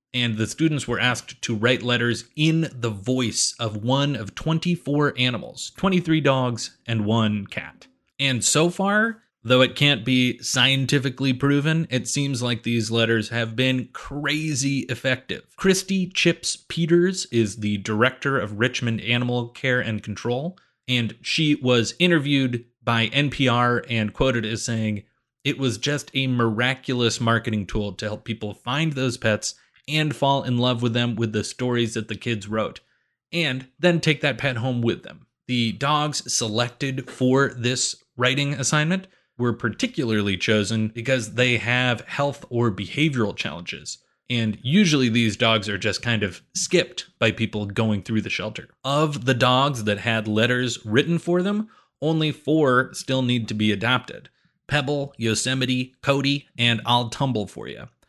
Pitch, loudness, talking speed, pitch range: 125 Hz, -22 LUFS, 155 wpm, 115-145 Hz